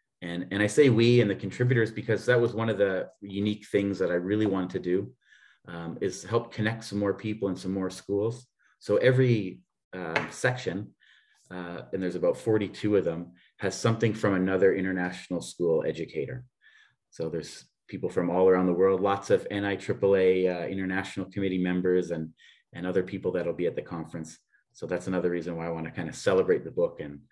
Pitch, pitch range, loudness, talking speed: 95 Hz, 90-110 Hz, -28 LUFS, 195 wpm